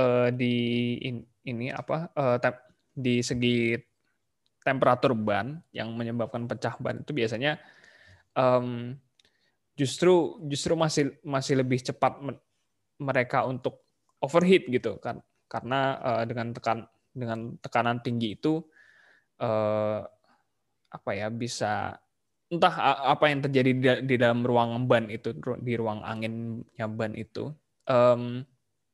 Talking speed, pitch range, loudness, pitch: 120 wpm, 115-135 Hz, -28 LUFS, 125 Hz